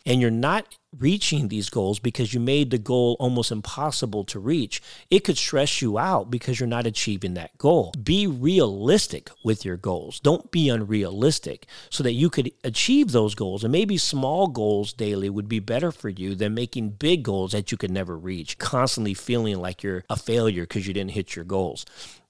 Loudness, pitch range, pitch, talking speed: -24 LUFS, 105-140 Hz, 115 Hz, 195 wpm